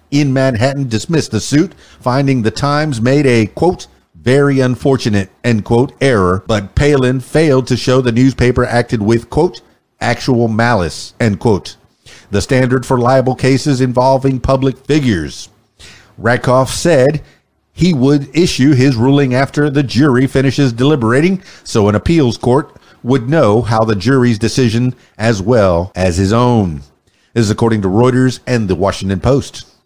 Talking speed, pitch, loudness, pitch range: 150 wpm, 125 Hz, -13 LUFS, 110-135 Hz